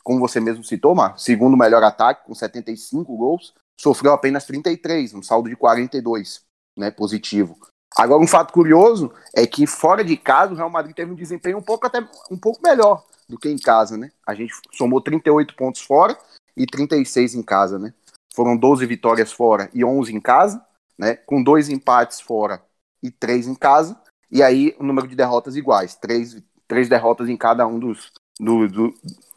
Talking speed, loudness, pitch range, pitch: 185 wpm, -17 LUFS, 115-155 Hz, 130 Hz